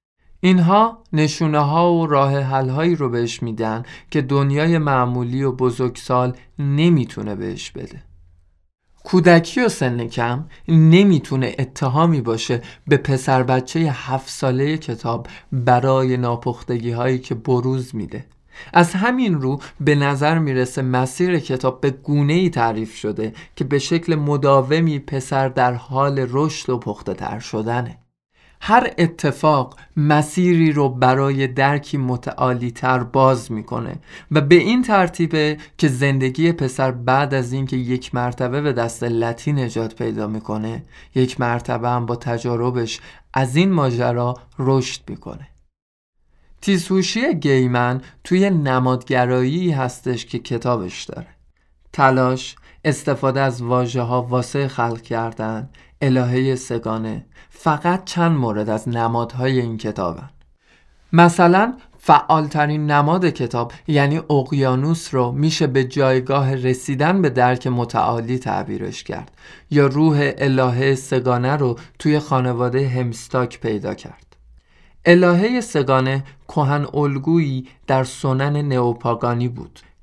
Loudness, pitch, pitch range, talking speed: -19 LUFS, 130 Hz, 125-150 Hz, 120 wpm